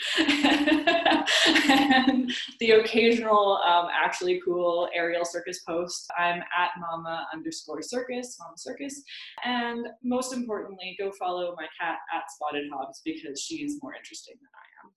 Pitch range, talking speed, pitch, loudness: 175-275 Hz, 135 wpm, 220 Hz, -26 LUFS